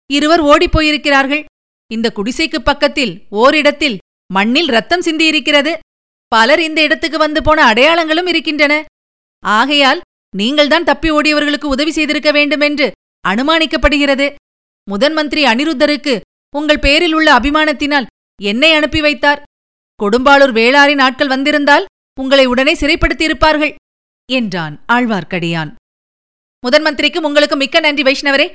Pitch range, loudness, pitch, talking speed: 265-310 Hz, -11 LUFS, 295 Hz, 100 wpm